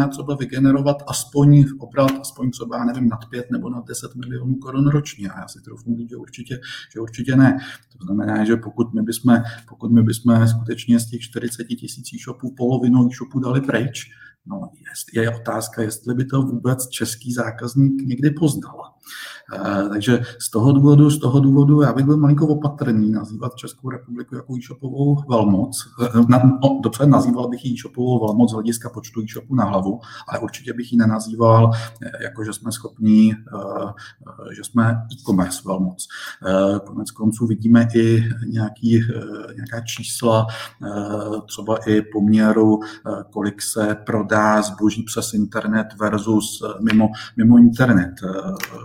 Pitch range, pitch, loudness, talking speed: 110-125 Hz, 115 Hz, -18 LUFS, 150 wpm